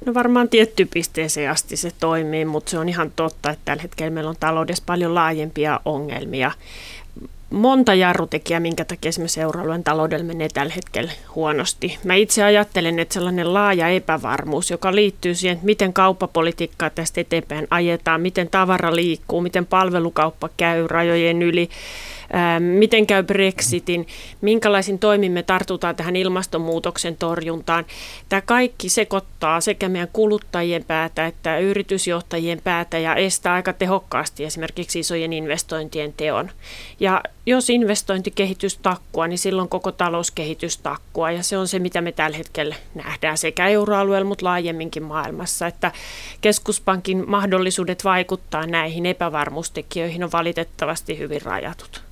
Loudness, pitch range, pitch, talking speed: -20 LUFS, 160-190 Hz, 170 Hz, 135 wpm